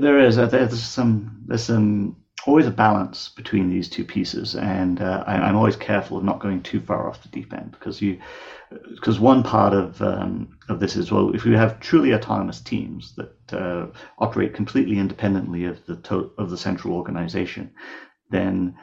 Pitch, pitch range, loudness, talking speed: 105 Hz, 95-115 Hz, -22 LUFS, 190 wpm